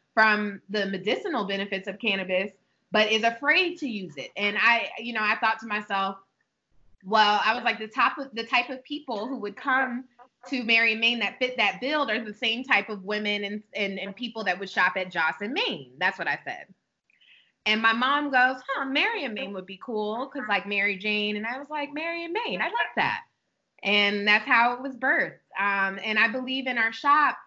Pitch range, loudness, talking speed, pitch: 205-260 Hz, -25 LUFS, 220 wpm, 225 Hz